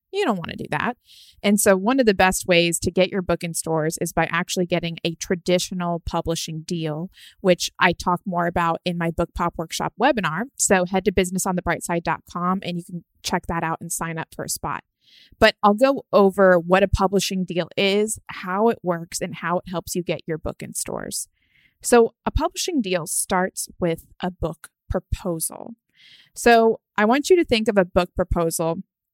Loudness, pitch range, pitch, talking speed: -22 LUFS, 170-200 Hz, 180 Hz, 195 wpm